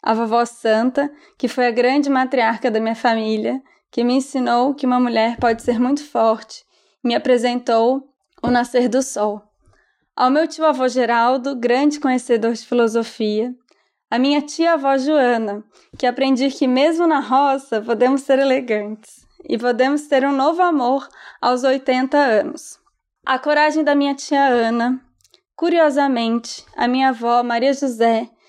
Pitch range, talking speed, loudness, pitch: 235-275 Hz, 145 wpm, -18 LUFS, 255 Hz